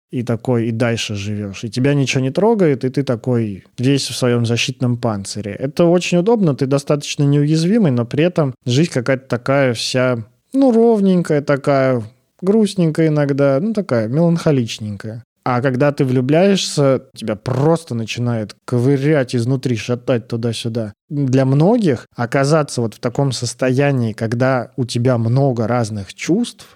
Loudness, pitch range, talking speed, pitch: -17 LUFS, 120-150 Hz, 140 wpm, 130 Hz